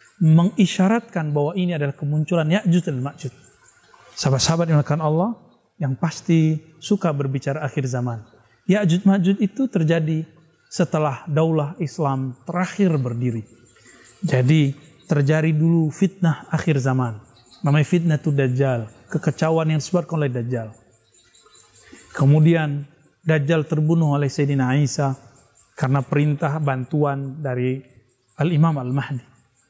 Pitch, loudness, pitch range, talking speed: 150 Hz, -21 LUFS, 130-165 Hz, 110 wpm